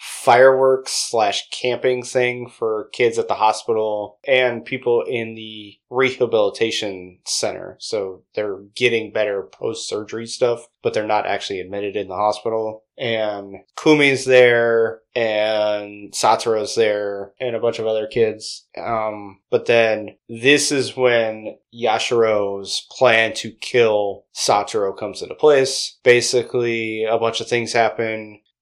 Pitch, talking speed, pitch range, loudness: 115 Hz, 130 wpm, 105-125 Hz, -19 LUFS